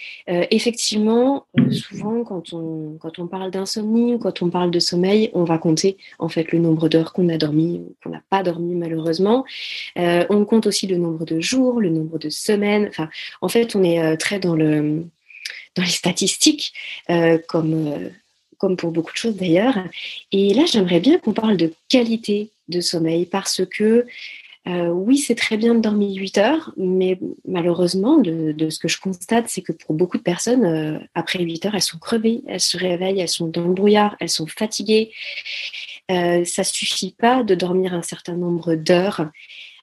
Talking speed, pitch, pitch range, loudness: 195 wpm, 185 Hz, 170-215 Hz, -19 LUFS